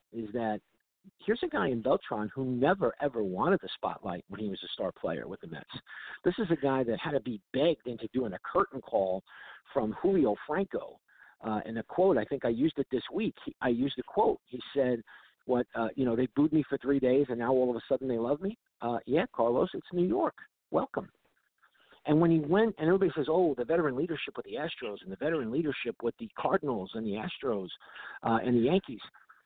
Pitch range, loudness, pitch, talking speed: 115-155 Hz, -31 LUFS, 130 Hz, 225 wpm